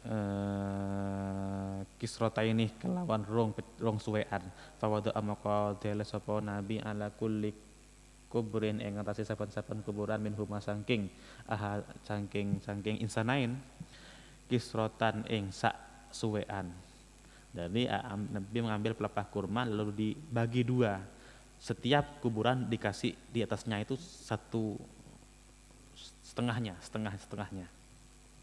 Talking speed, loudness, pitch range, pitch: 105 wpm, -36 LUFS, 105-115 Hz, 105 Hz